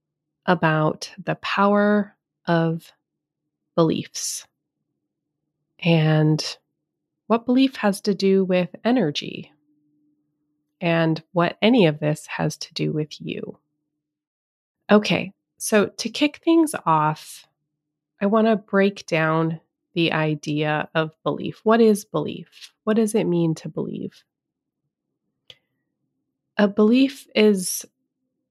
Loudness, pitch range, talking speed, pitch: -21 LUFS, 155-210 Hz, 105 wpm, 170 Hz